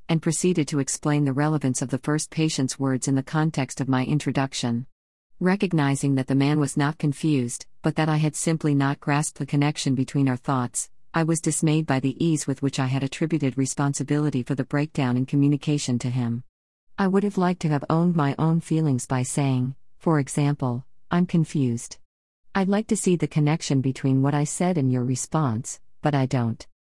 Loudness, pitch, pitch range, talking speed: -24 LUFS, 145 Hz, 135-155 Hz, 195 wpm